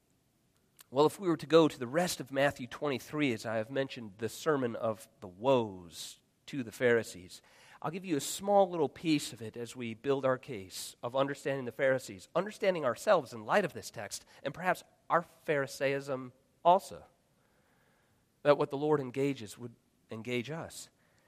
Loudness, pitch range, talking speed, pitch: -33 LUFS, 115-150 Hz, 175 wpm, 135 Hz